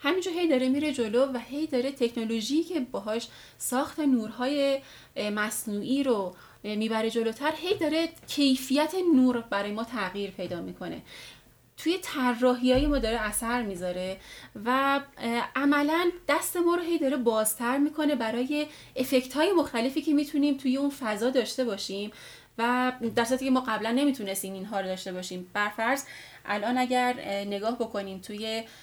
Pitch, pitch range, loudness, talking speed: 250 Hz, 220-285 Hz, -28 LUFS, 145 wpm